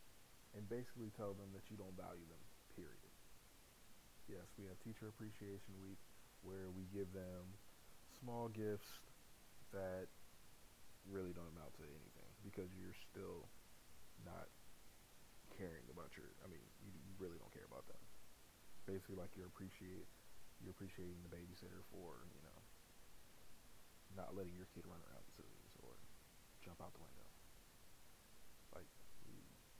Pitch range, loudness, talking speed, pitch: 90-100 Hz, -57 LUFS, 135 wpm, 95 Hz